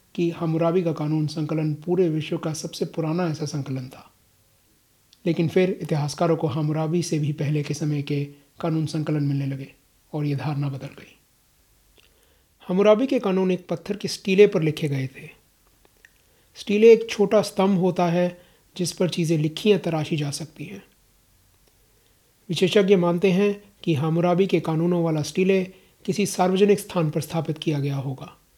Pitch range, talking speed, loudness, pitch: 150-185 Hz, 160 wpm, -23 LUFS, 165 Hz